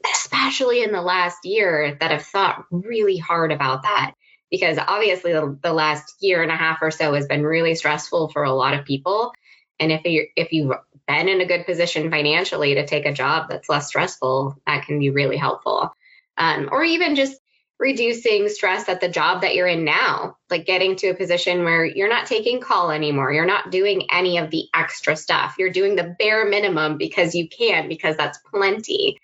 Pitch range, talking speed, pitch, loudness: 155-220 Hz, 200 wpm, 175 Hz, -20 LUFS